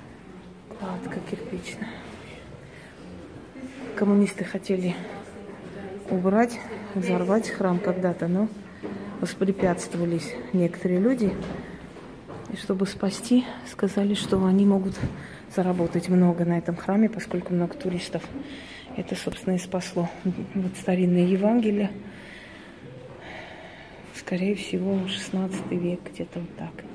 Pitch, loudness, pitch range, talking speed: 190 Hz, -26 LUFS, 180-205 Hz, 90 wpm